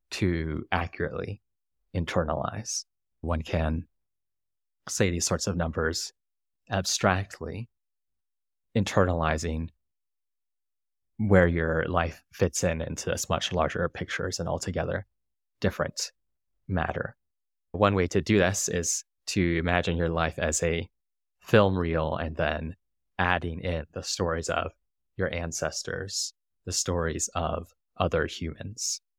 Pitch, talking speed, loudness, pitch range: 85 Hz, 110 wpm, -28 LUFS, 80-95 Hz